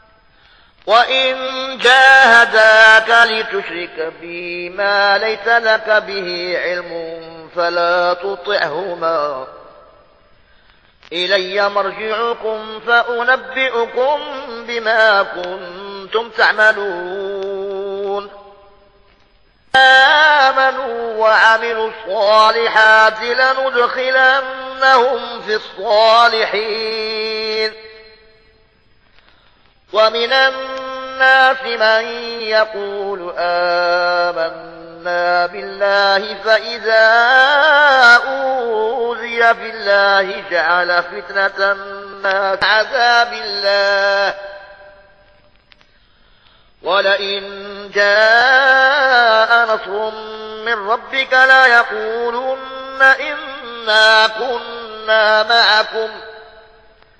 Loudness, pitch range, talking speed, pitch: -13 LUFS, 195-235 Hz, 50 wpm, 220 Hz